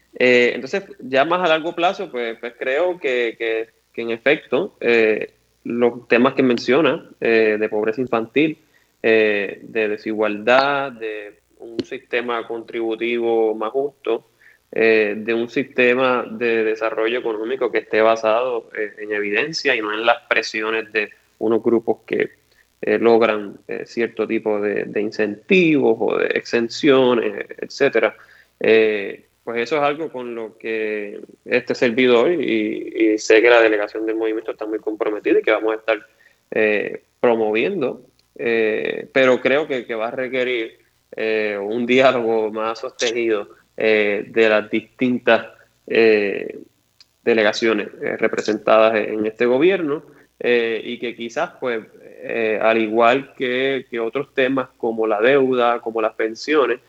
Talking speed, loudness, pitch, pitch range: 145 wpm, -19 LUFS, 115 Hz, 110-130 Hz